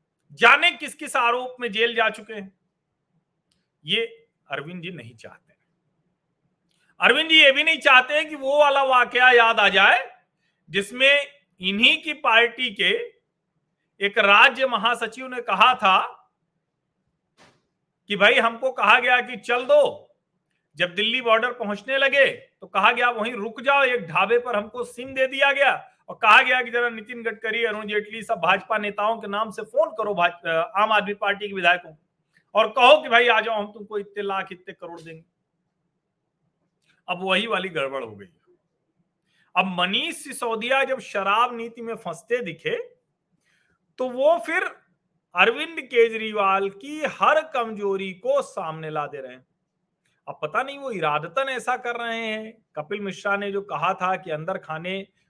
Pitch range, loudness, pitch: 175-245 Hz, -20 LUFS, 210 Hz